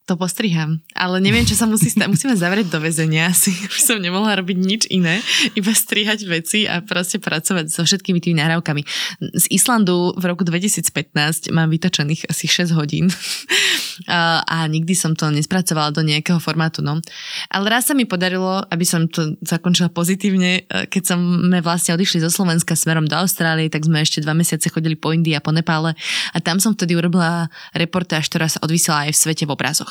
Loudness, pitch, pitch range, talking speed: -17 LUFS, 175 Hz, 160-190 Hz, 185 wpm